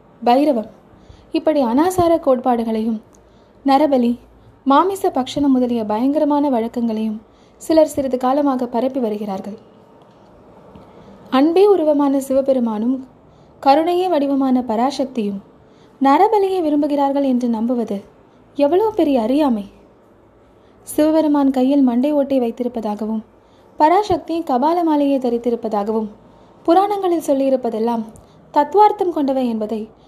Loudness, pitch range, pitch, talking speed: -17 LUFS, 230-300 Hz, 270 Hz, 80 wpm